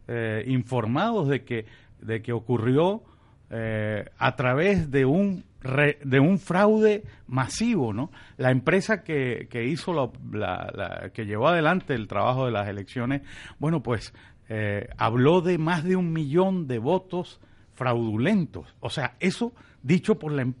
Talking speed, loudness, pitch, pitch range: 155 wpm, -25 LUFS, 130 Hz, 115-175 Hz